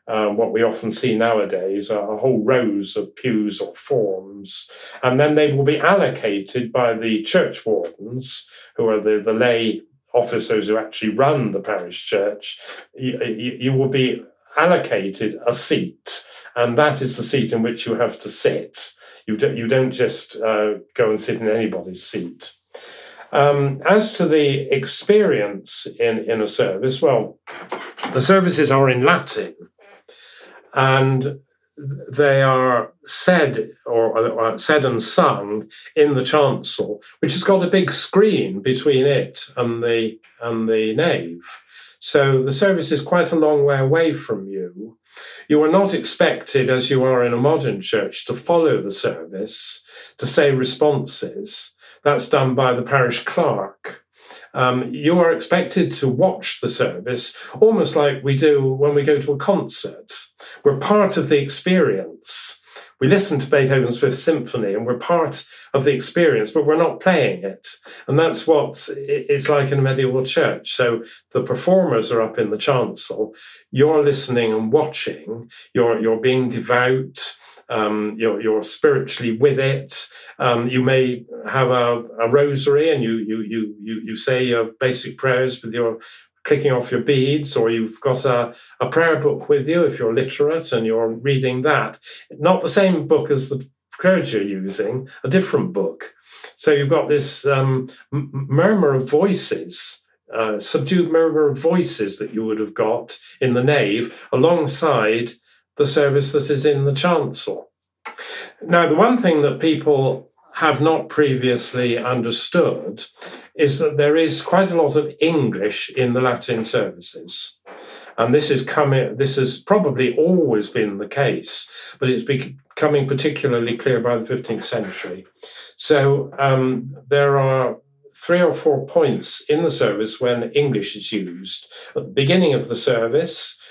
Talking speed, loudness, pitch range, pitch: 160 wpm, -19 LUFS, 120-155 Hz, 135 Hz